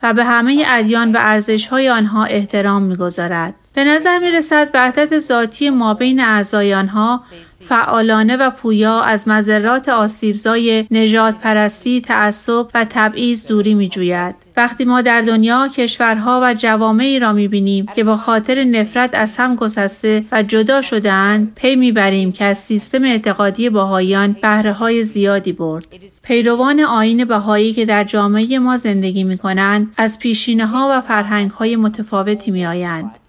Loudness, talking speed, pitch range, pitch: -14 LUFS, 155 wpm, 205-240 Hz, 220 Hz